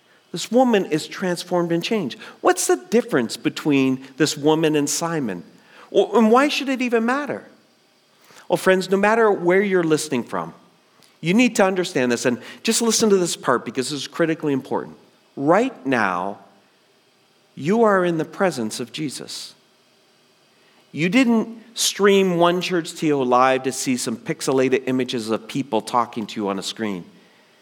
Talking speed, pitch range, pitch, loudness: 165 wpm, 130-200 Hz, 170 Hz, -20 LUFS